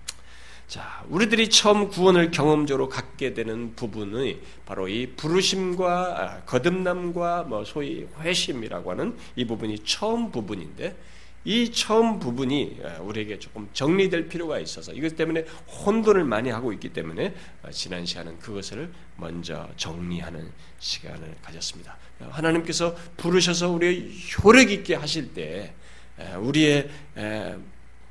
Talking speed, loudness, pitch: 290 characters per minute, -24 LUFS, 150 Hz